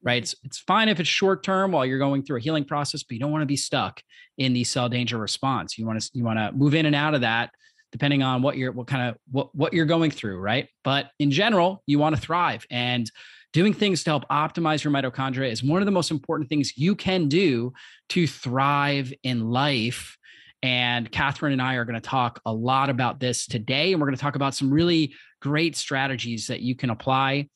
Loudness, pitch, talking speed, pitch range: -24 LUFS, 140 Hz, 235 wpm, 125-155 Hz